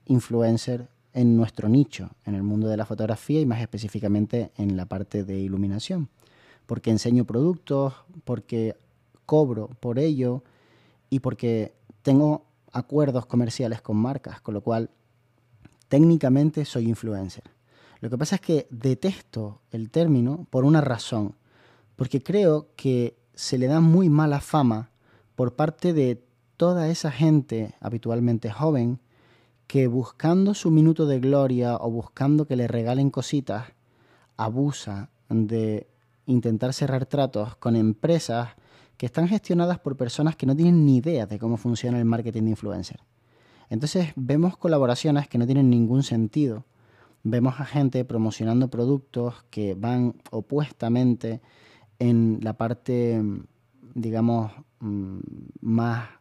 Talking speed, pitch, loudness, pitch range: 130 wpm, 120 Hz, -24 LUFS, 115-140 Hz